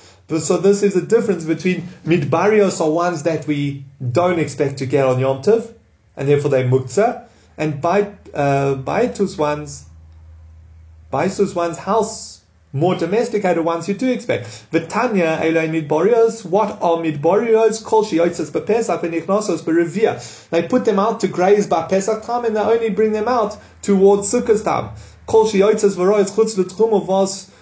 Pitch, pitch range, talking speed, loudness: 180 Hz, 150-210 Hz, 135 wpm, -18 LUFS